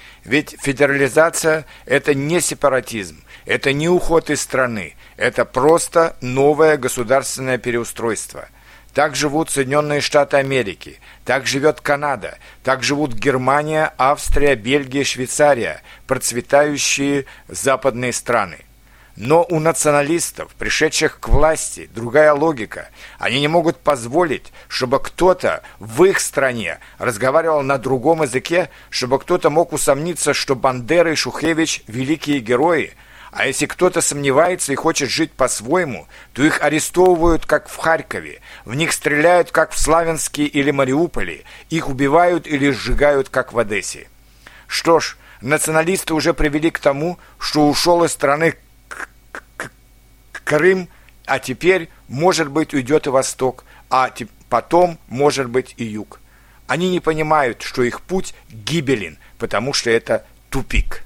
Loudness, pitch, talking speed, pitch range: -17 LUFS, 145 Hz, 125 wpm, 130-160 Hz